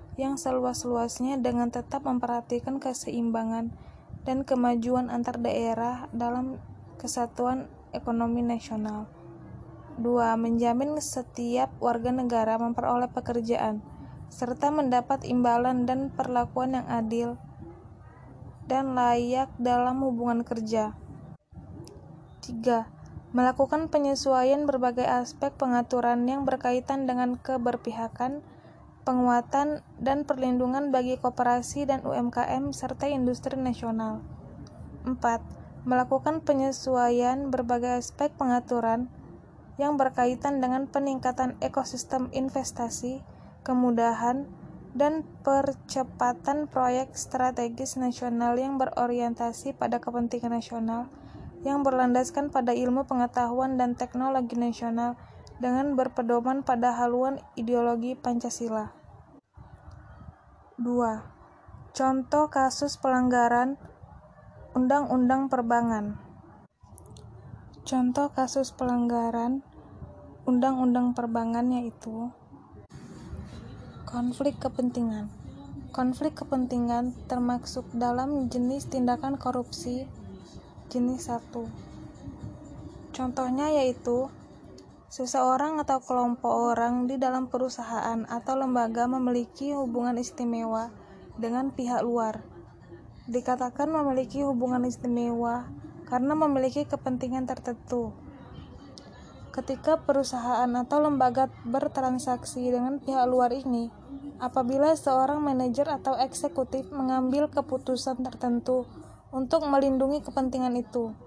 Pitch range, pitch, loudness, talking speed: 240-265 Hz, 250 Hz, -28 LUFS, 85 wpm